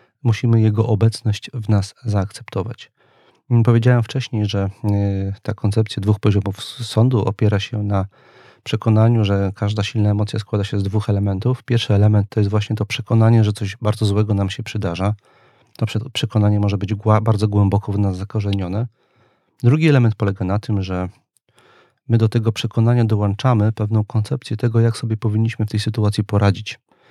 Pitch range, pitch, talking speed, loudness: 100-115 Hz, 110 Hz, 155 wpm, -19 LUFS